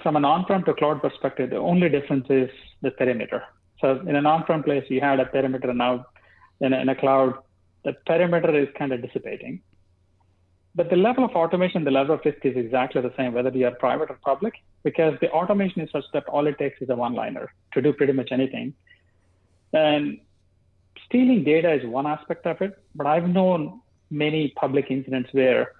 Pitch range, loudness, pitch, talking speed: 130-160 Hz, -23 LUFS, 140 Hz, 200 wpm